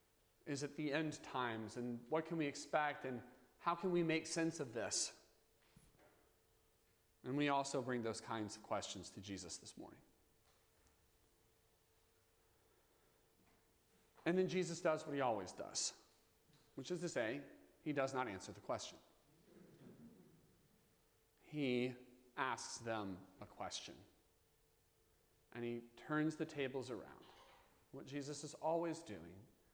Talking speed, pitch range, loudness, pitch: 130 wpm, 110-155 Hz, -44 LUFS, 130 Hz